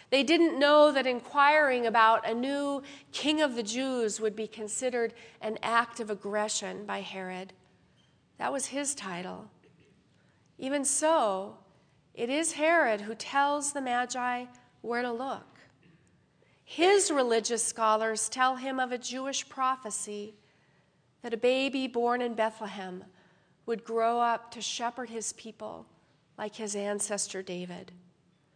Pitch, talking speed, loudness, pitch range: 235 Hz, 130 wpm, -29 LUFS, 215-265 Hz